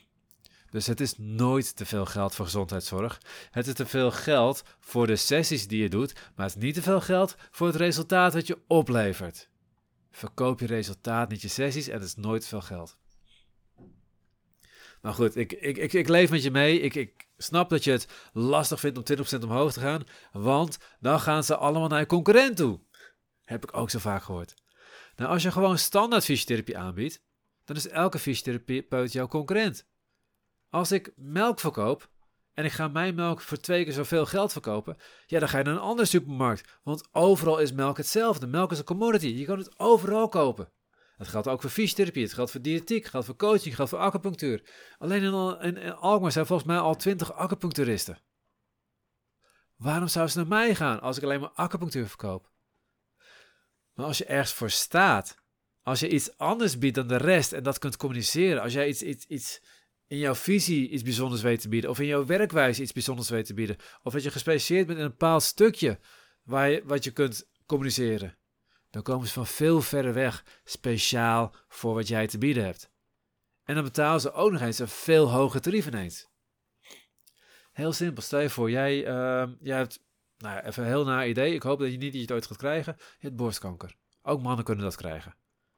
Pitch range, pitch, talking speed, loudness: 115-165 Hz, 140 Hz, 200 wpm, -27 LUFS